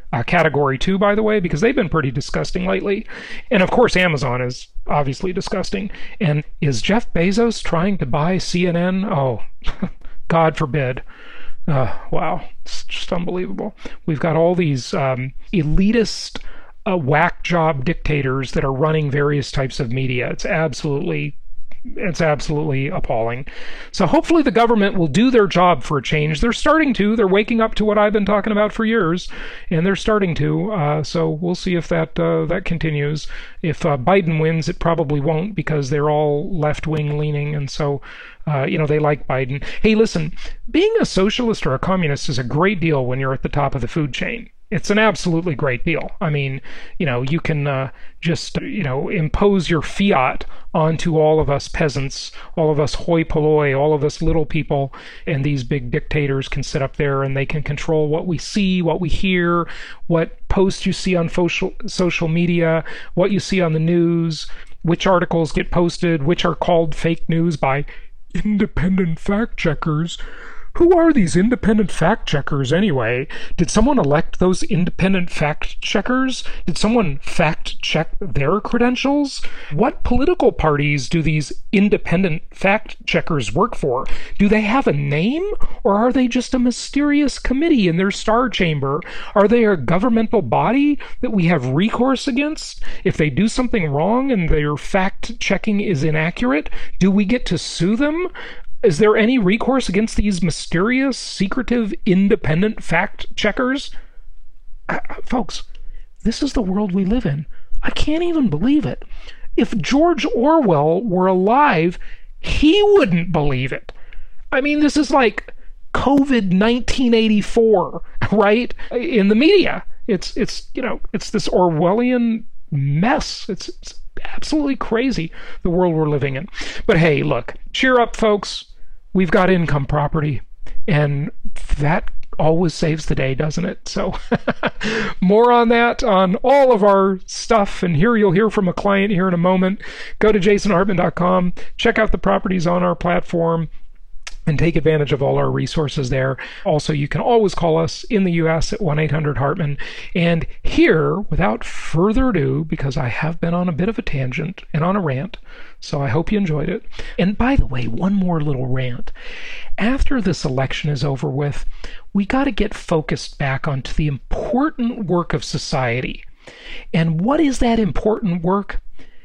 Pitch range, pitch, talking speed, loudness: 155-215 Hz, 175 Hz, 170 wpm, -18 LUFS